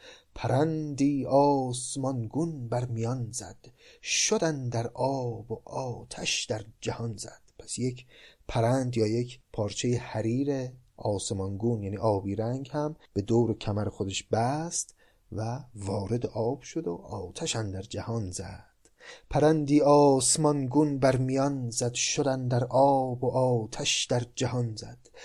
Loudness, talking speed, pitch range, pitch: -28 LUFS, 125 wpm, 110-135 Hz, 125 Hz